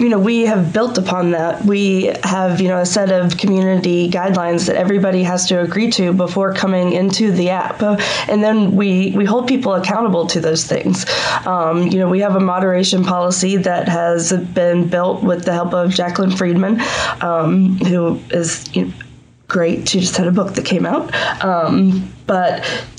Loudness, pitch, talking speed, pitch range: -15 LUFS, 185 Hz, 185 wpm, 175-195 Hz